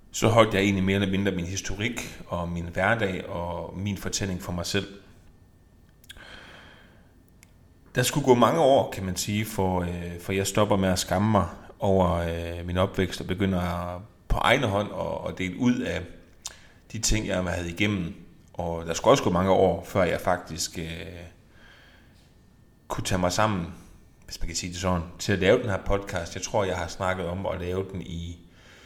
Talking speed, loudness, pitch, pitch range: 185 wpm, -26 LUFS, 90 Hz, 85-100 Hz